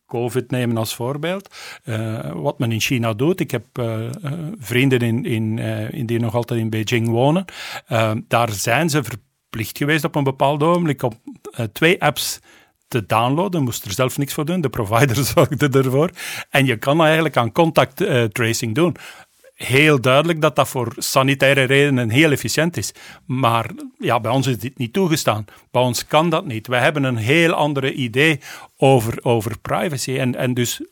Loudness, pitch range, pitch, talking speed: -19 LUFS, 120-150 Hz, 130 Hz, 175 wpm